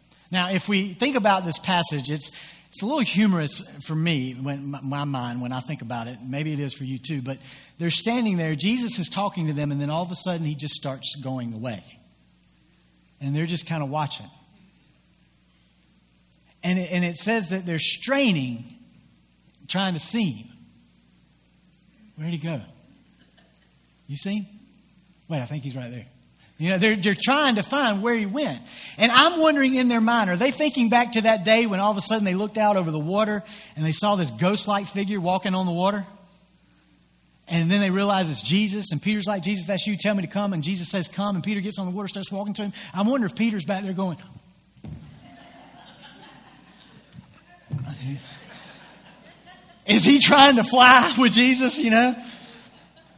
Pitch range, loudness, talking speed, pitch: 145-210 Hz, -21 LUFS, 190 wpm, 185 Hz